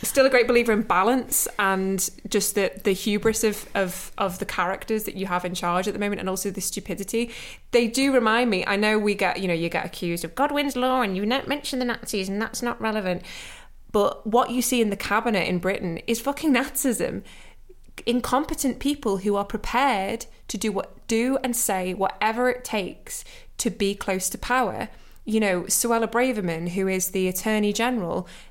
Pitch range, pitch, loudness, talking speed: 195-245 Hz, 215 Hz, -24 LUFS, 195 wpm